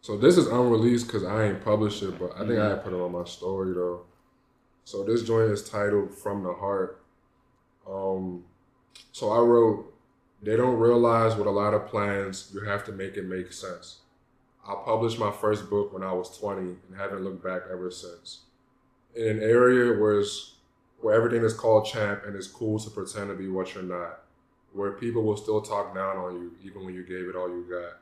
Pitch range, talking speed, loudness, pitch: 95-110 Hz, 210 wpm, -26 LUFS, 100 Hz